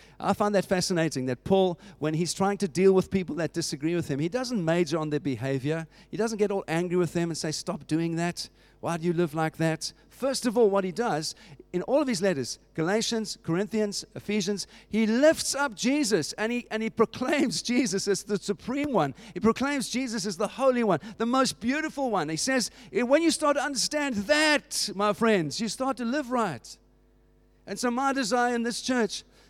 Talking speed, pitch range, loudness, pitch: 210 wpm, 165-245 Hz, -27 LUFS, 205 Hz